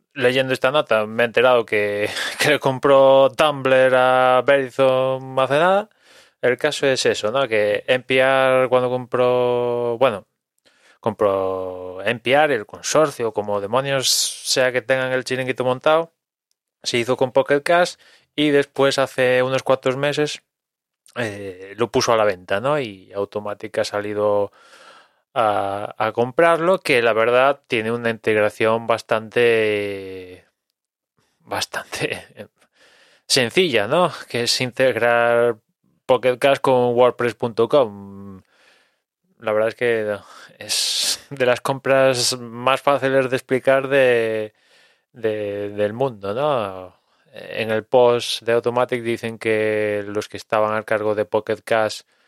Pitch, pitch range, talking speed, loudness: 125 Hz, 110-135 Hz, 125 wpm, -19 LUFS